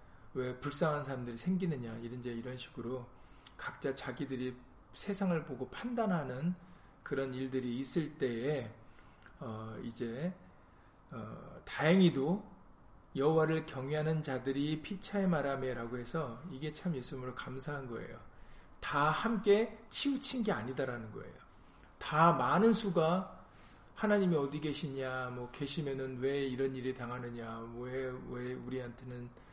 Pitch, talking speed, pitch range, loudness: 135 Hz, 280 characters per minute, 125-160 Hz, -36 LUFS